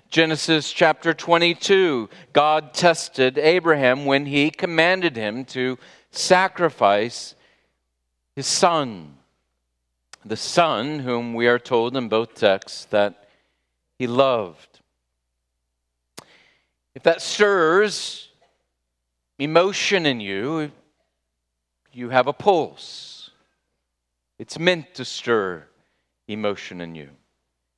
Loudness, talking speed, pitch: -20 LUFS, 95 wpm, 120 Hz